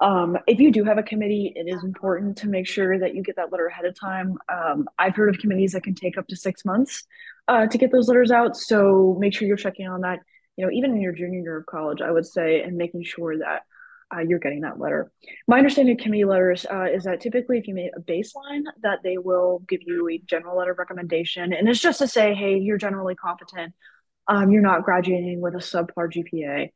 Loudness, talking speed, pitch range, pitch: -22 LUFS, 240 wpm, 180-215 Hz, 190 Hz